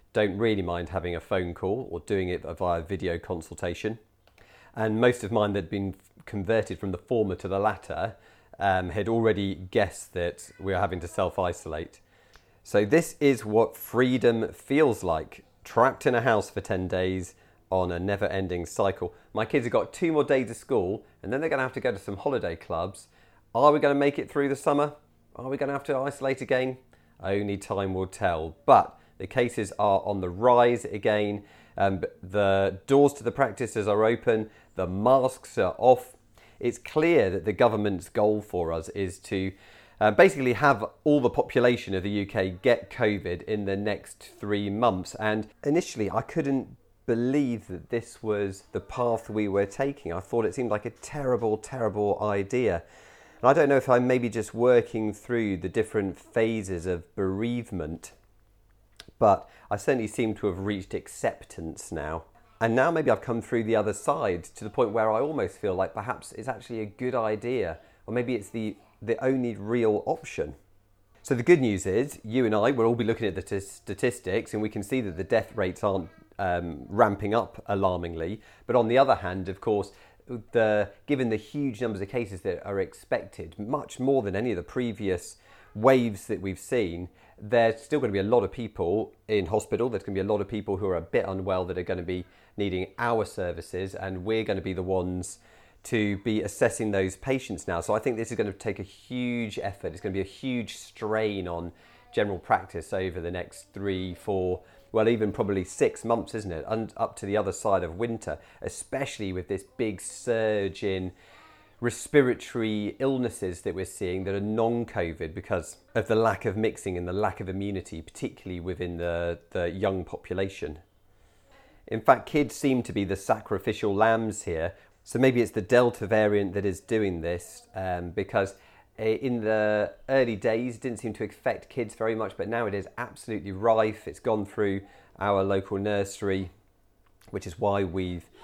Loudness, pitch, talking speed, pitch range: -27 LUFS, 105 Hz, 190 wpm, 95-115 Hz